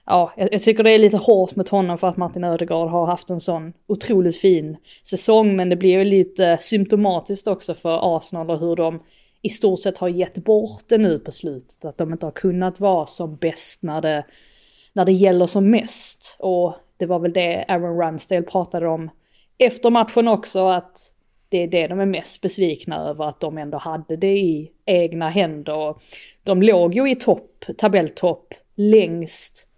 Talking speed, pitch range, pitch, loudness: 190 wpm, 165-195 Hz, 180 Hz, -19 LUFS